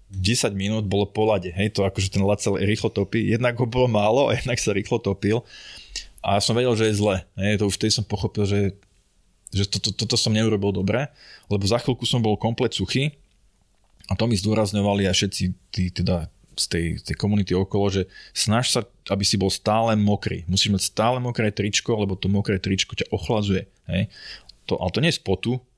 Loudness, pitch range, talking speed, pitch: -23 LUFS, 100-115 Hz, 205 wpm, 105 Hz